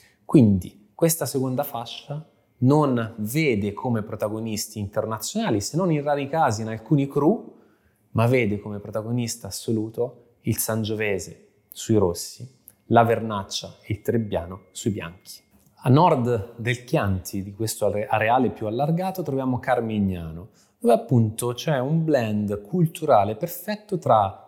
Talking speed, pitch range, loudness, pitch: 125 wpm, 105-140 Hz, -24 LUFS, 115 Hz